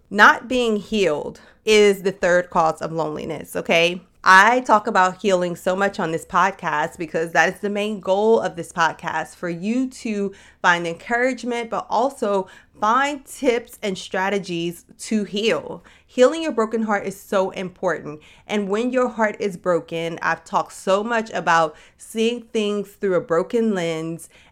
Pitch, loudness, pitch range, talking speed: 195 Hz, -20 LUFS, 175-220 Hz, 160 wpm